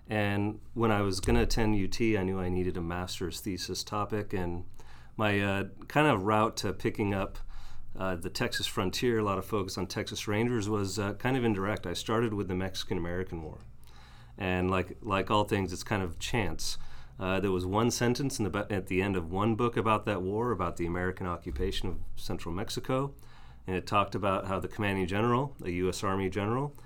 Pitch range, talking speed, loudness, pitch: 90-110 Hz, 205 wpm, -31 LUFS, 100 Hz